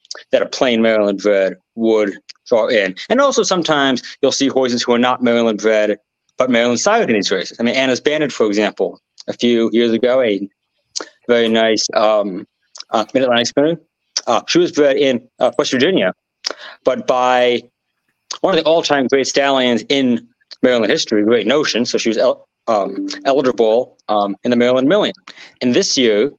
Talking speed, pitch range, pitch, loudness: 175 wpm, 115-140 Hz, 120 Hz, -15 LUFS